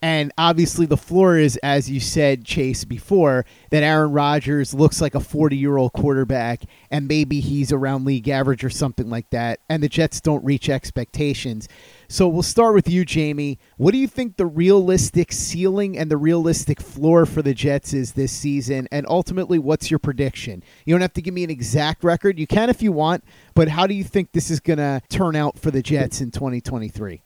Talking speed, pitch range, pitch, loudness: 205 wpm, 135-170 Hz, 150 Hz, -20 LUFS